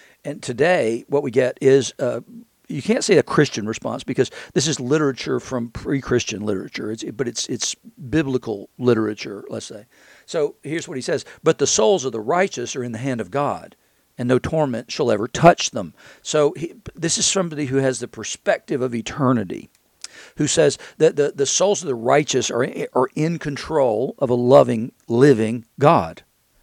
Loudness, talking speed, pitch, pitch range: -20 LUFS, 185 wpm, 140 Hz, 120-160 Hz